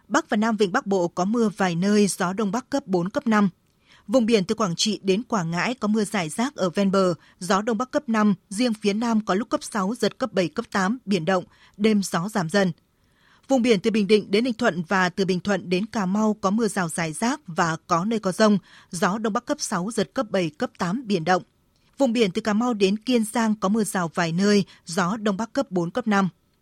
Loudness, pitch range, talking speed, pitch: -23 LUFS, 190-230 Hz, 250 wpm, 205 Hz